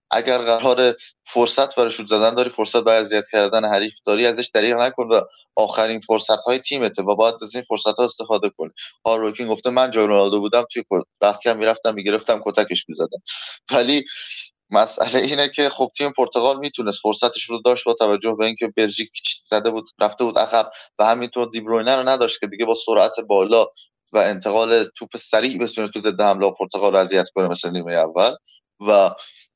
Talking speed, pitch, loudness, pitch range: 185 wpm, 115 Hz, -19 LUFS, 105-120 Hz